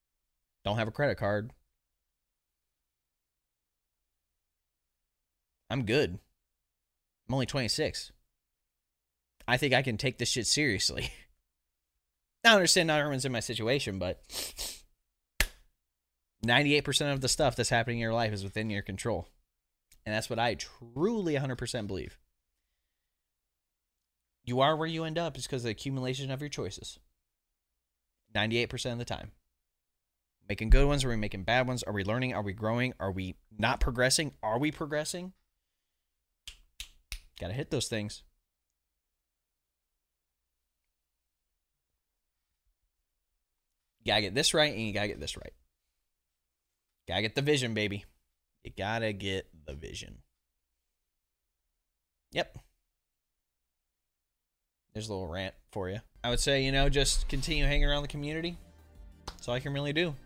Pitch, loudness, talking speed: 75 Hz, -31 LUFS, 135 wpm